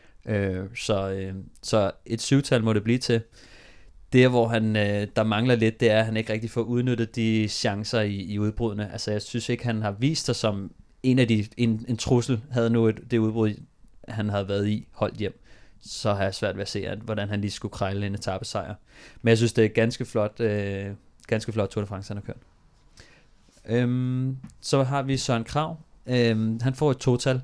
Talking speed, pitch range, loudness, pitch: 215 wpm, 105-120 Hz, -25 LUFS, 110 Hz